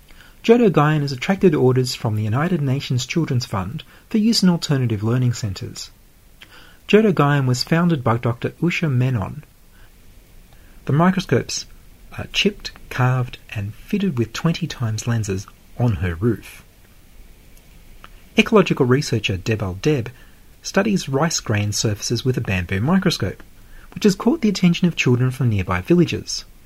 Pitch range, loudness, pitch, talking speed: 105-165 Hz, -19 LUFS, 125 Hz, 135 wpm